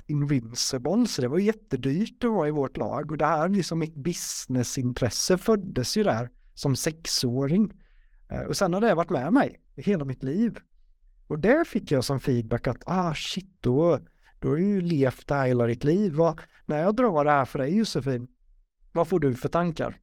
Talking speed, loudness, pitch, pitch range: 190 wpm, -26 LUFS, 150 Hz, 130-185 Hz